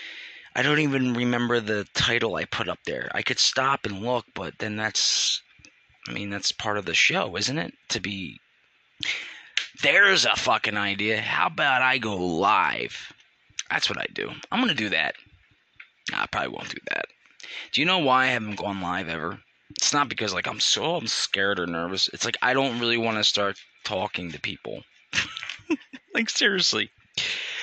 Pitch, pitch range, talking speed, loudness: 115 Hz, 100-130 Hz, 180 wpm, -24 LUFS